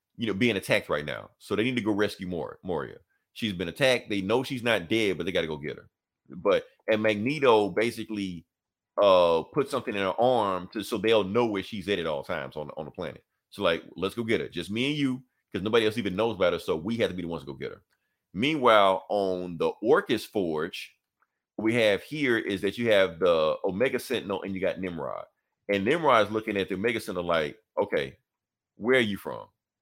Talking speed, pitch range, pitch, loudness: 230 wpm, 95-125 Hz, 105 Hz, -27 LUFS